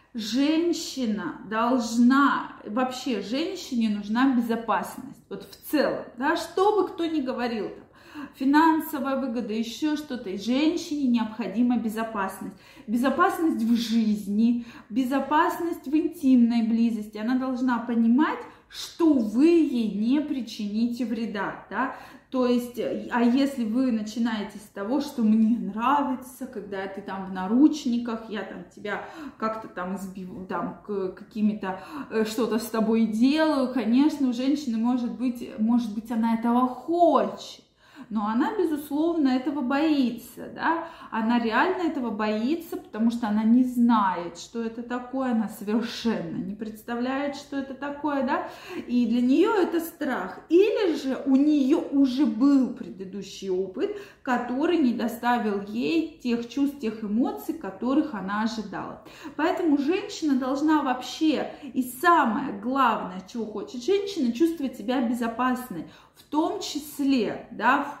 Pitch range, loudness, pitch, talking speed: 225-290 Hz, -25 LUFS, 250 Hz, 130 wpm